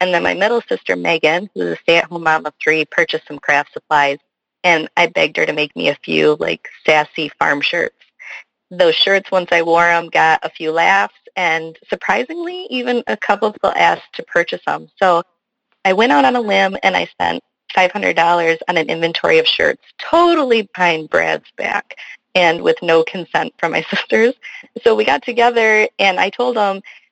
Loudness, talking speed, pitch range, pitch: -15 LUFS, 185 wpm, 165-245 Hz, 180 Hz